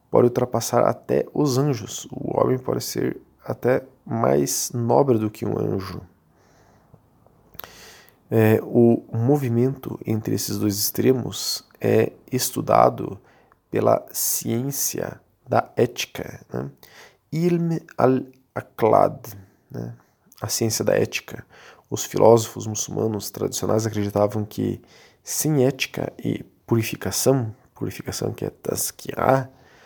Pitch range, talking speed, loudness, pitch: 105-130 Hz, 100 wpm, -22 LUFS, 115 Hz